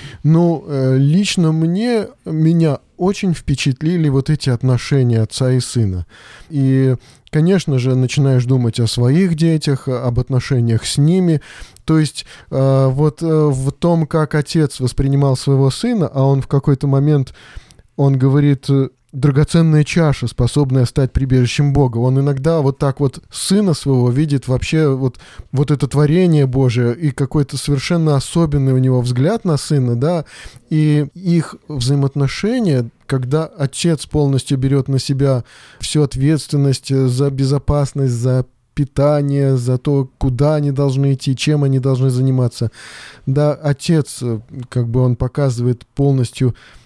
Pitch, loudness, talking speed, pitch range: 140 Hz, -16 LUFS, 135 wpm, 130-150 Hz